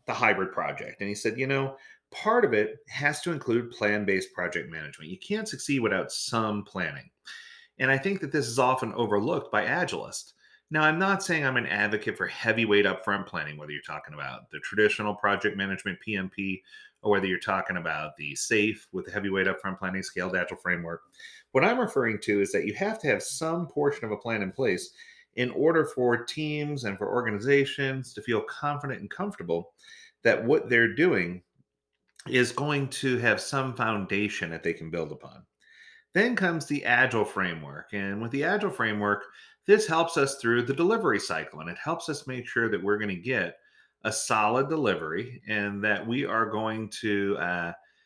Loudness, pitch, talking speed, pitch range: -27 LUFS, 115 Hz, 190 wpm, 100-140 Hz